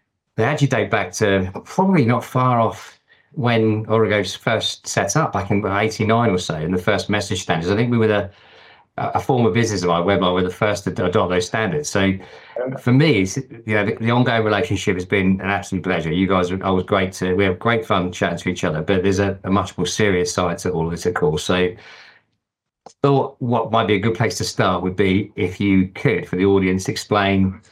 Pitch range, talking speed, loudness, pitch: 95-115 Hz, 230 wpm, -19 LUFS, 100 Hz